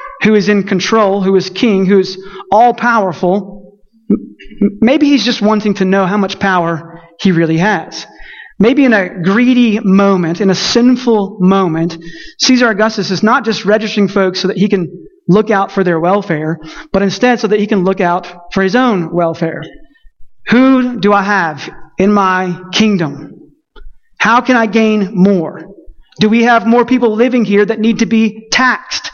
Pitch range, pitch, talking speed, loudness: 185-230 Hz, 200 Hz, 175 wpm, -11 LUFS